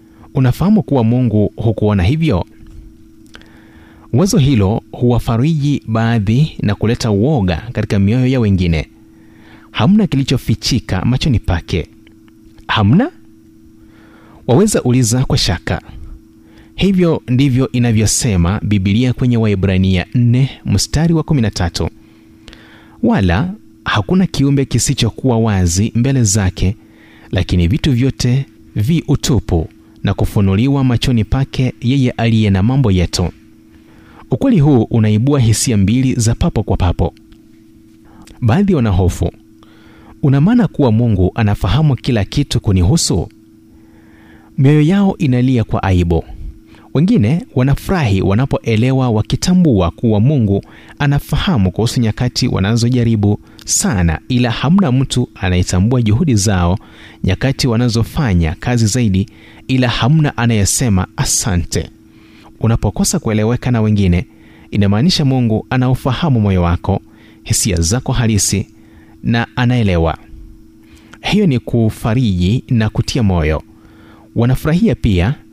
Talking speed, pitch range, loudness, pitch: 100 wpm, 100-125 Hz, -14 LUFS, 110 Hz